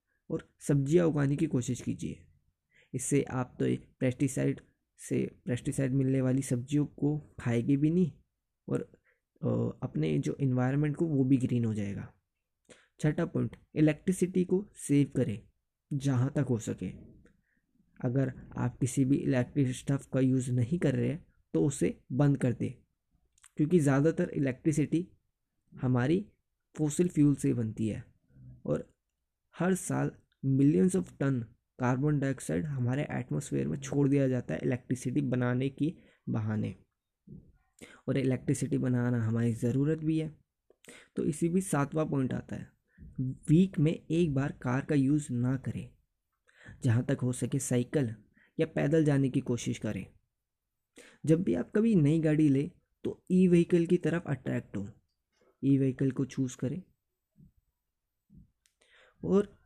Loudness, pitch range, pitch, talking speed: -31 LUFS, 125-155 Hz, 135 Hz, 140 wpm